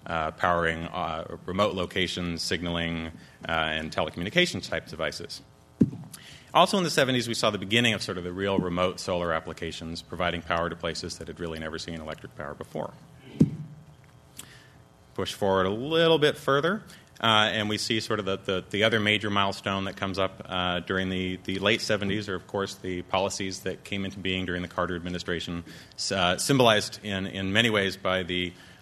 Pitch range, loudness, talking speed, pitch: 85-105 Hz, -27 LUFS, 180 wpm, 95 Hz